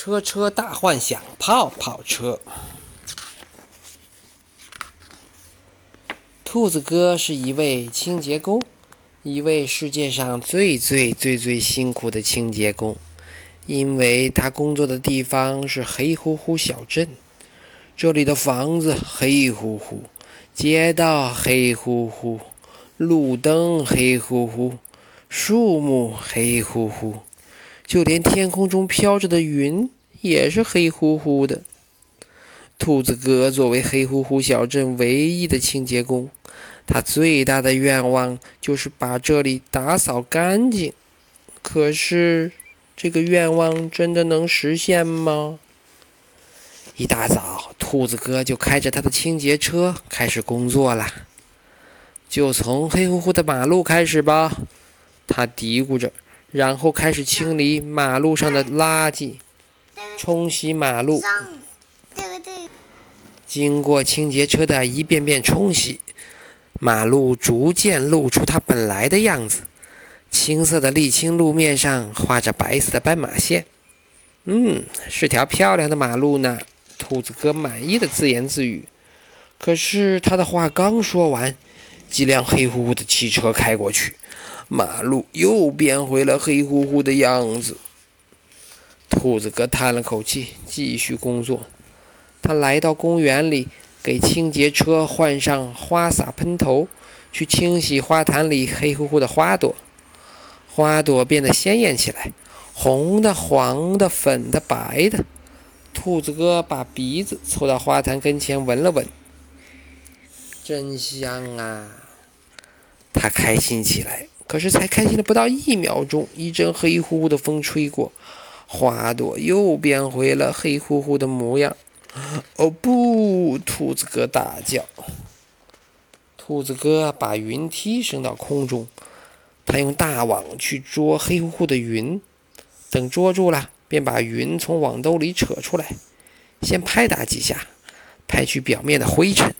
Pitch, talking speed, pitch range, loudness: 145 Hz, 185 characters per minute, 125-165 Hz, -19 LUFS